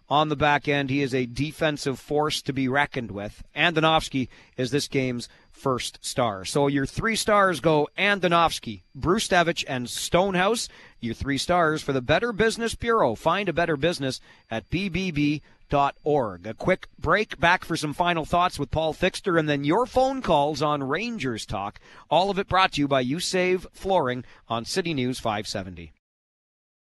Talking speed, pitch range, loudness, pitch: 170 wpm, 130-175 Hz, -24 LUFS, 150 Hz